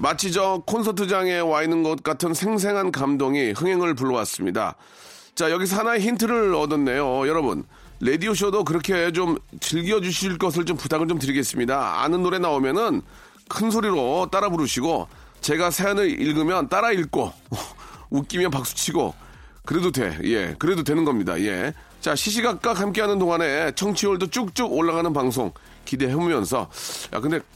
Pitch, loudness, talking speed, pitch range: 180 Hz, -23 LUFS, 340 characters per minute, 160-205 Hz